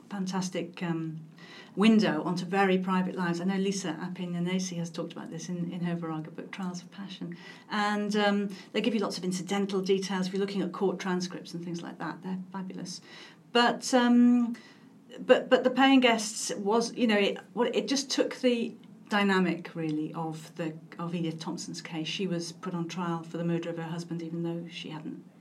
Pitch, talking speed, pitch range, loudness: 185 Hz, 195 wpm, 170-210 Hz, -29 LUFS